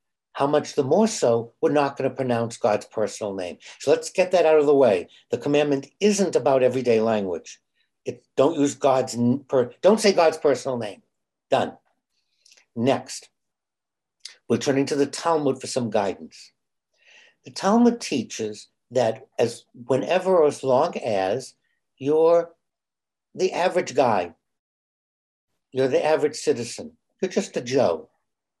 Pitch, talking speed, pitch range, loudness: 145 Hz, 140 wpm, 130-180 Hz, -22 LUFS